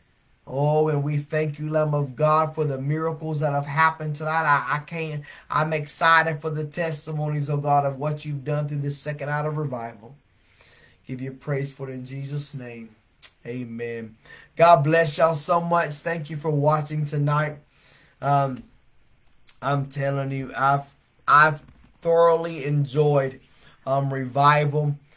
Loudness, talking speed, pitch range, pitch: -23 LUFS, 155 wpm, 135-155 Hz, 145 Hz